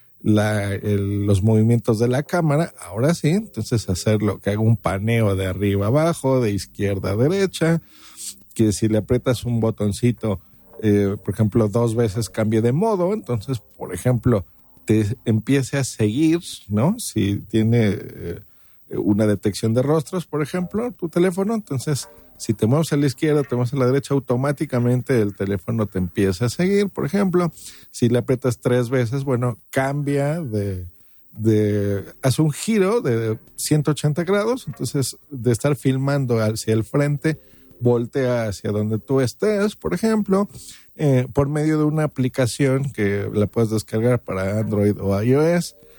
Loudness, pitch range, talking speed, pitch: -21 LUFS, 105-145 Hz, 155 wpm, 120 Hz